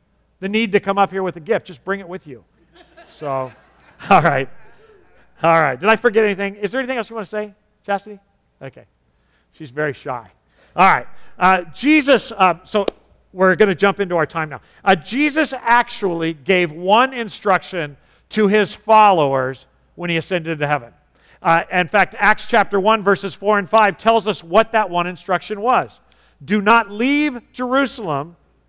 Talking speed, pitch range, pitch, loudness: 180 wpm, 165-220 Hz, 195 Hz, -17 LUFS